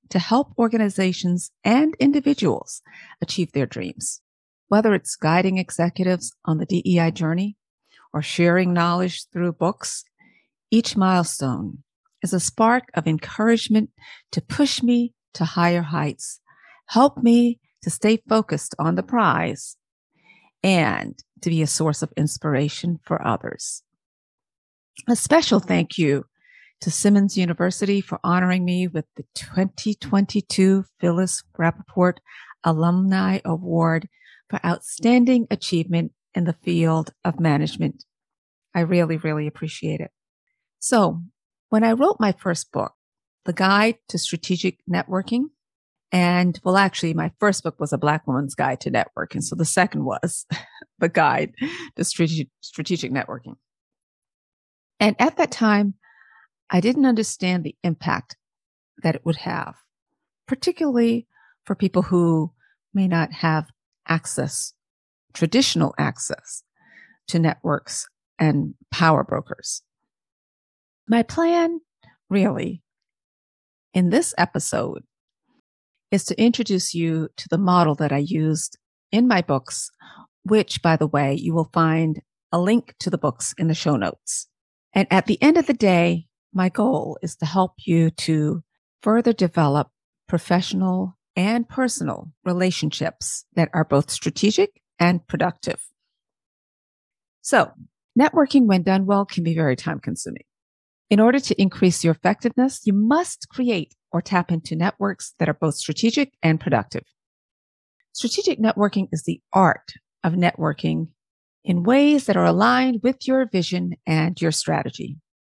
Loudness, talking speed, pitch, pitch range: -21 LUFS, 130 wpm, 180 Hz, 160-210 Hz